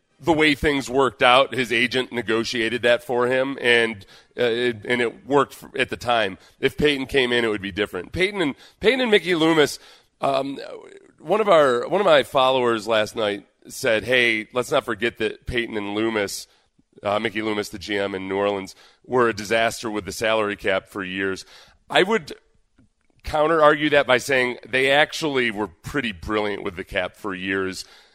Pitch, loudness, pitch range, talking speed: 120 Hz, -21 LUFS, 105-135 Hz, 190 wpm